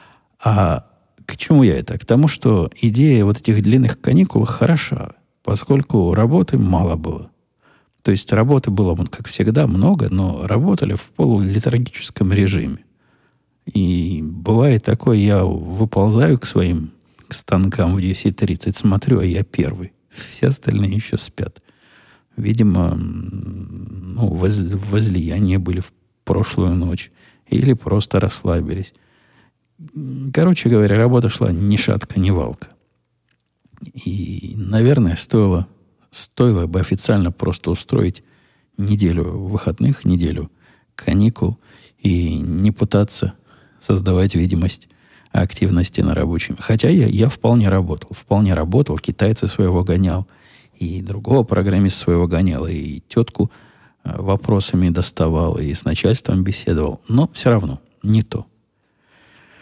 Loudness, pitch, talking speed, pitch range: -17 LUFS, 100 Hz, 115 wpm, 90-115 Hz